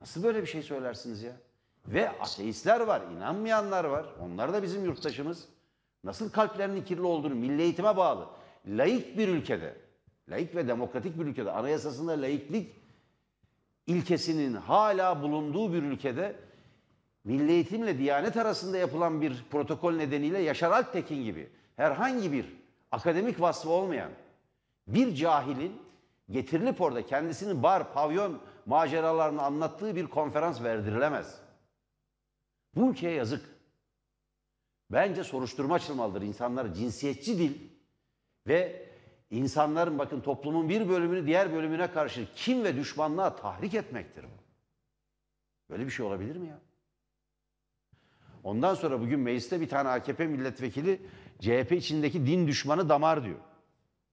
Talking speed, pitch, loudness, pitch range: 120 wpm, 155 Hz, -30 LUFS, 135-180 Hz